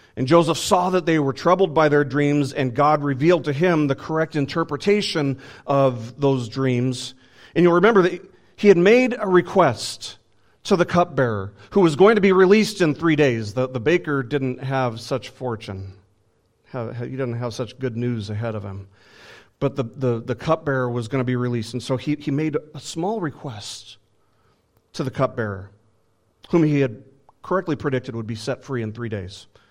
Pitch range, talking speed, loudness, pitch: 115-160 Hz, 185 wpm, -21 LUFS, 135 Hz